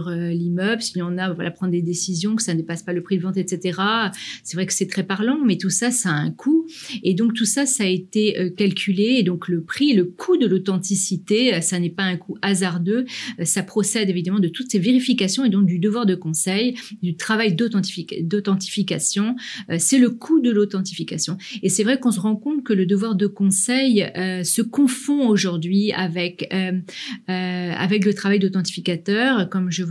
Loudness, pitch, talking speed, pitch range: -20 LUFS, 195 Hz, 205 wpm, 180-225 Hz